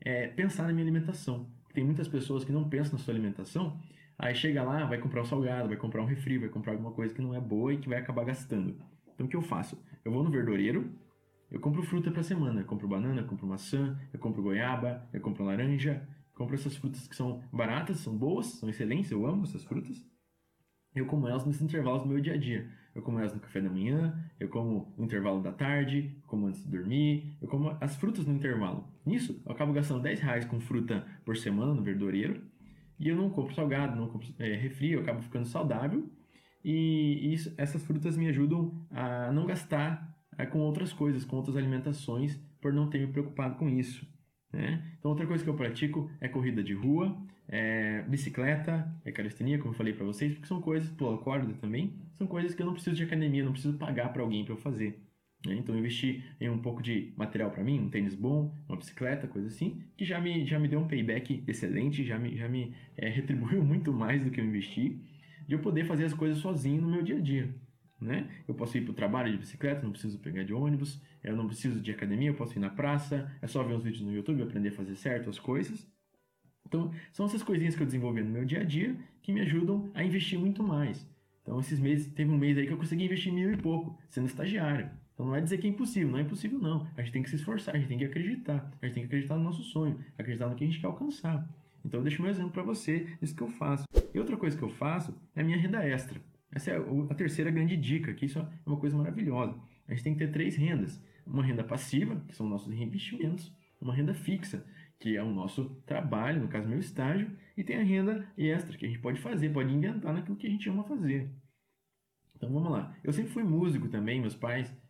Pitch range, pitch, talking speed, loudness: 125-160 Hz, 145 Hz, 235 wpm, -33 LUFS